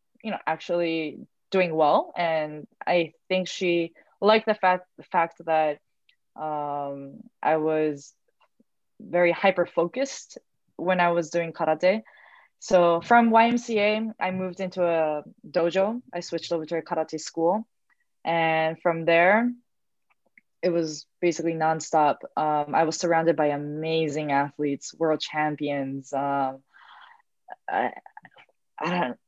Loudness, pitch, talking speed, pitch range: -25 LUFS, 170 Hz, 125 wpm, 155-185 Hz